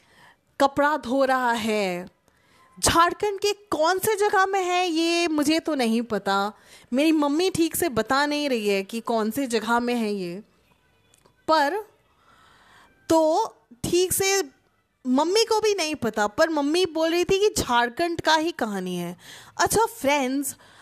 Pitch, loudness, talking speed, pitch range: 295 Hz, -23 LUFS, 155 wpm, 235-350 Hz